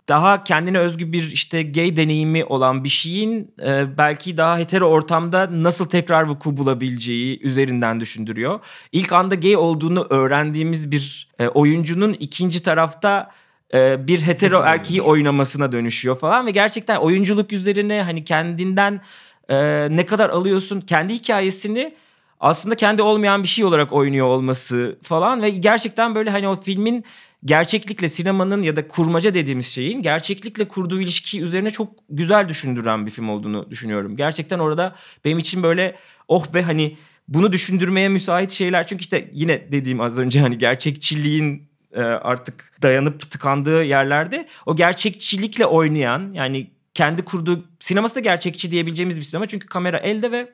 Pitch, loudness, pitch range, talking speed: 170 Hz, -19 LUFS, 145-195 Hz, 145 wpm